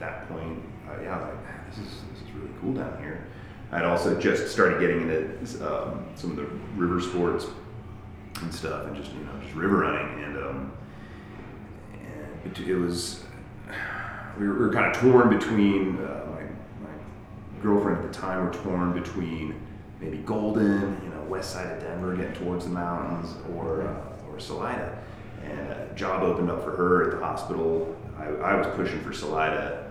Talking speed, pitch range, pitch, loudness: 185 wpm, 85-105 Hz, 95 Hz, -28 LUFS